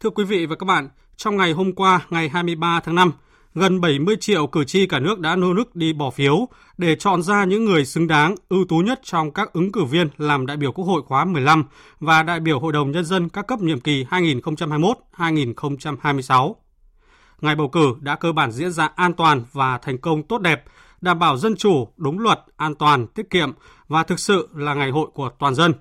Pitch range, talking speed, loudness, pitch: 150-185 Hz, 220 wpm, -19 LUFS, 165 Hz